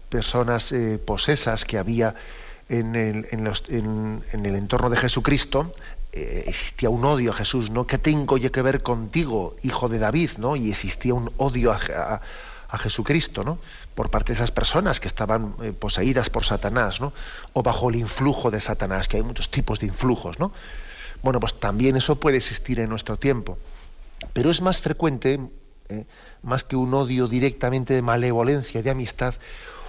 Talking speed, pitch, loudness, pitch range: 180 wpm, 120 Hz, -24 LUFS, 110-135 Hz